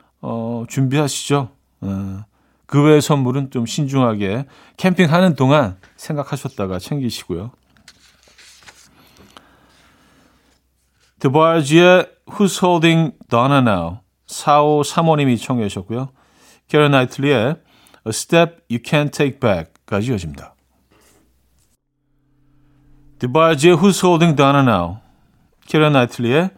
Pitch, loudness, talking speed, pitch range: 140 Hz, -16 LUFS, 300 characters per minute, 115-155 Hz